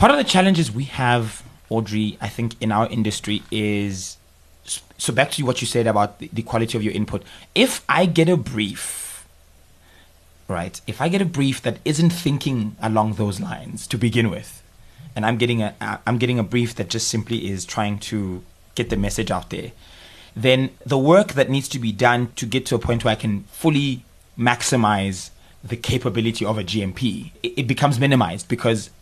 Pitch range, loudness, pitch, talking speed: 100-130 Hz, -21 LUFS, 115 Hz, 190 wpm